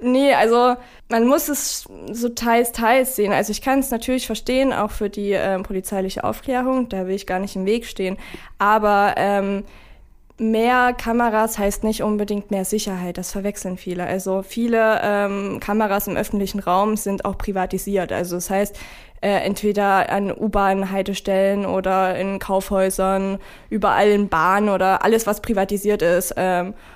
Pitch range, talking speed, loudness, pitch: 190-220 Hz, 160 wpm, -20 LUFS, 200 Hz